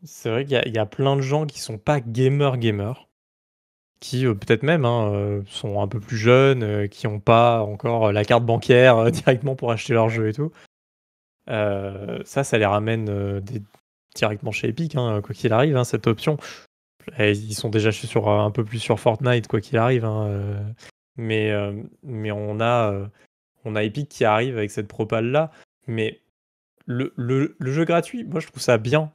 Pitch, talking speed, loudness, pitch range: 115 Hz, 205 wpm, -22 LUFS, 105-130 Hz